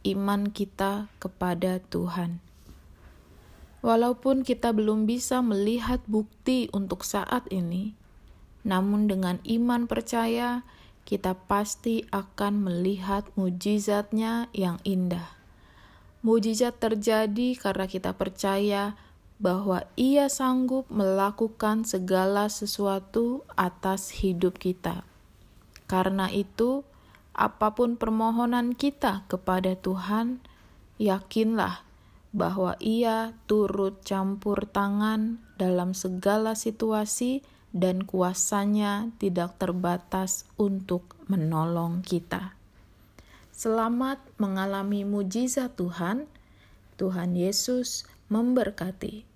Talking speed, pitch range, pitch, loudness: 85 wpm, 185-225 Hz, 200 Hz, -28 LUFS